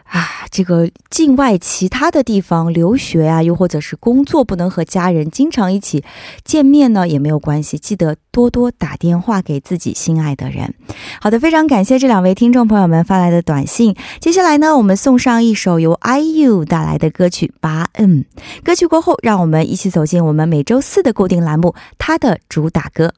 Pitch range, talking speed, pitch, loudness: 165-245 Hz, 300 characters per minute, 185 Hz, -13 LUFS